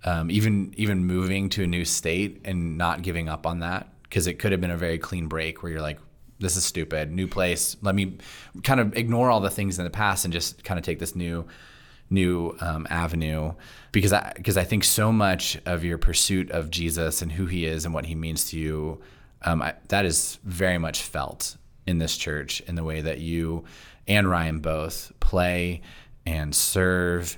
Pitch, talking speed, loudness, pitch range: 85 Hz, 210 wpm, -25 LUFS, 80-95 Hz